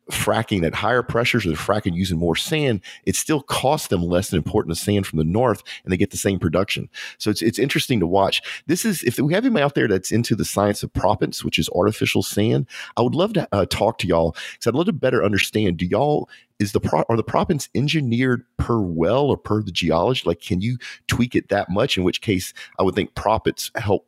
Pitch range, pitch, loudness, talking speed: 90-125 Hz, 105 Hz, -21 LUFS, 240 wpm